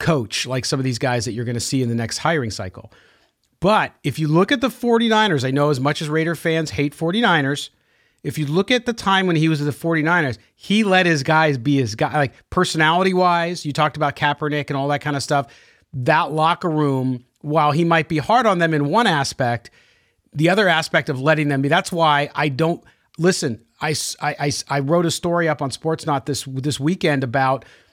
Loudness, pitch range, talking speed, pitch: -19 LUFS, 140-165 Hz, 220 wpm, 150 Hz